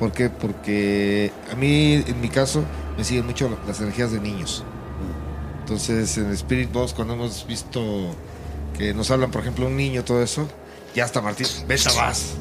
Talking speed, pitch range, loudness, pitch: 170 wpm, 100-125 Hz, -23 LUFS, 110 Hz